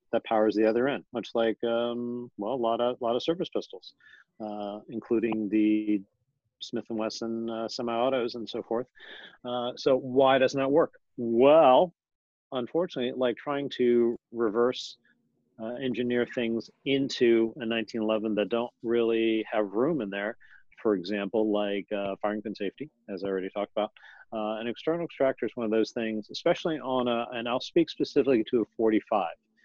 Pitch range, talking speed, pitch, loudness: 110-125 Hz, 170 wpm, 115 Hz, -28 LUFS